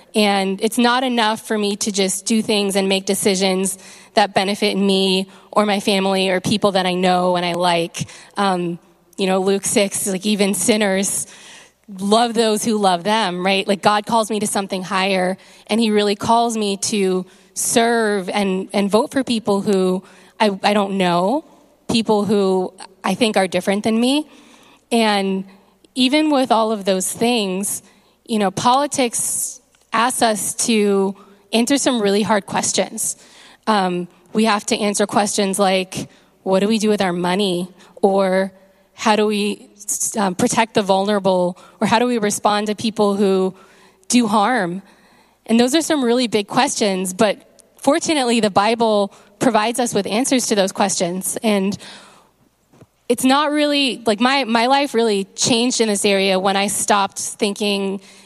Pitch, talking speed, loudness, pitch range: 205 Hz, 165 wpm, -18 LUFS, 195-225 Hz